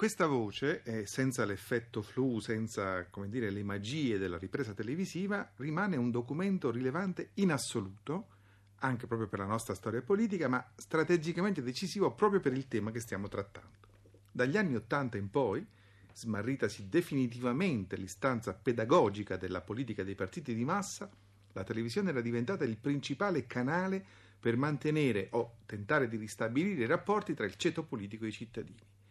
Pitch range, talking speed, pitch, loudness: 100-145 Hz, 150 wpm, 120 Hz, -35 LUFS